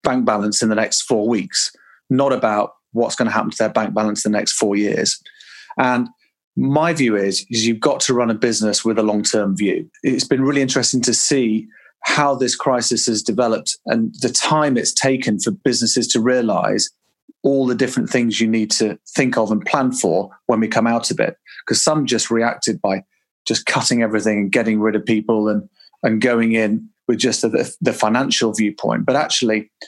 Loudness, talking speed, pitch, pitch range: -18 LUFS, 205 wpm, 115 Hz, 110-125 Hz